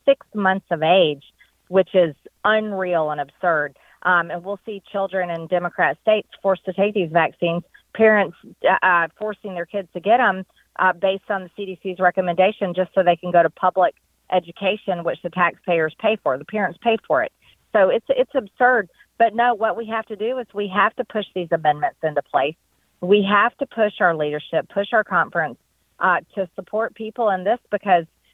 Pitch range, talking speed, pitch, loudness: 175-215 Hz, 190 wpm, 190 Hz, -20 LUFS